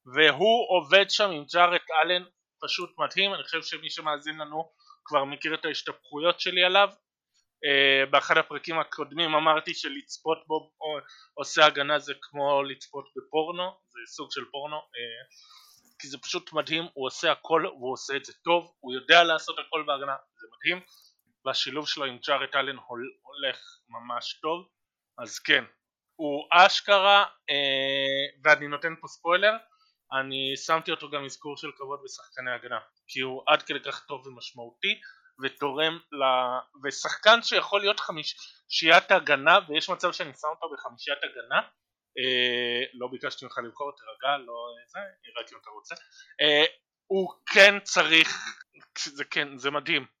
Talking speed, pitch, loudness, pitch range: 145 wpm, 155 Hz, -25 LUFS, 140-180 Hz